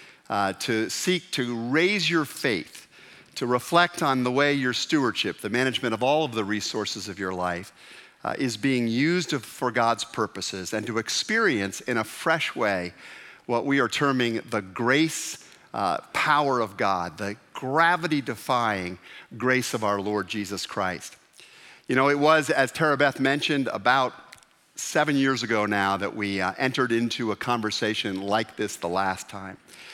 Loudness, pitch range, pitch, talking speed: -25 LUFS, 105-140 Hz, 120 Hz, 165 wpm